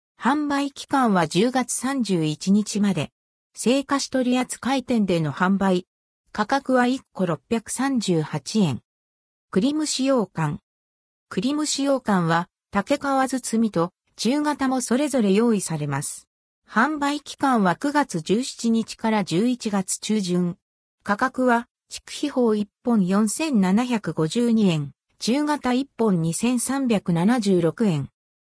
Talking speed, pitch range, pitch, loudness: 175 characters per minute, 180-260 Hz, 225 Hz, -23 LUFS